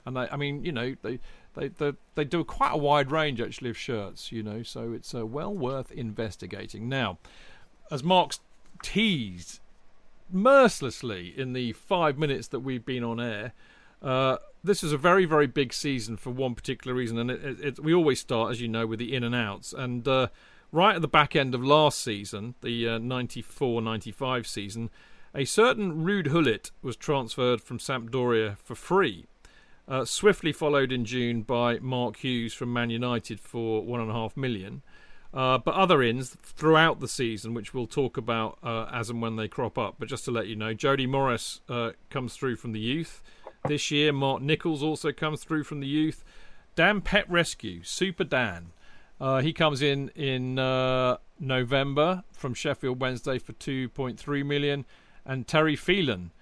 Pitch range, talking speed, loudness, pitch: 115-150 Hz, 180 wpm, -27 LUFS, 130 Hz